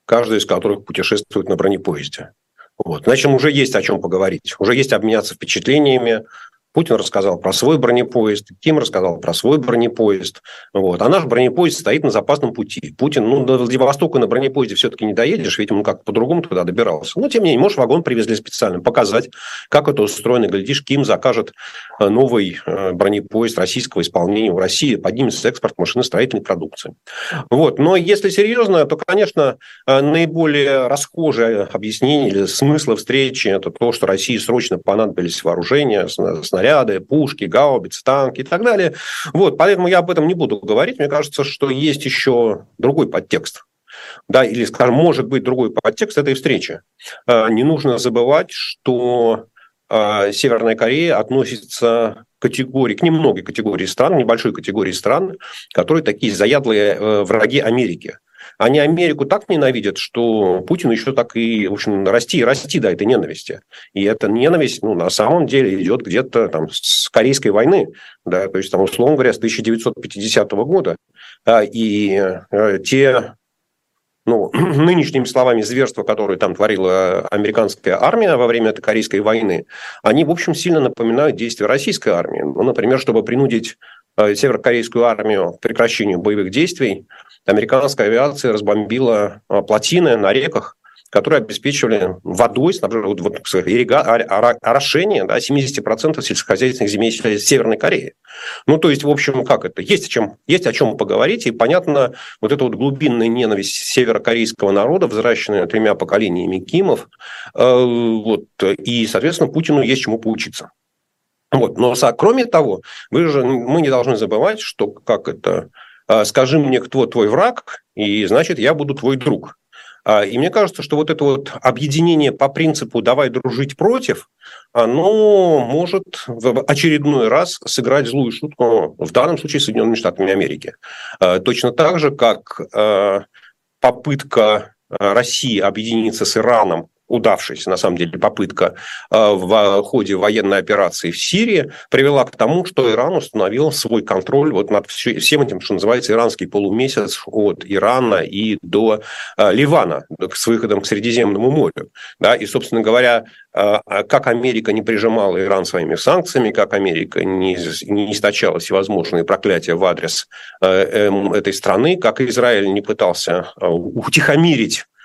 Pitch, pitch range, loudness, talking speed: 120 Hz, 110-140 Hz, -15 LUFS, 145 wpm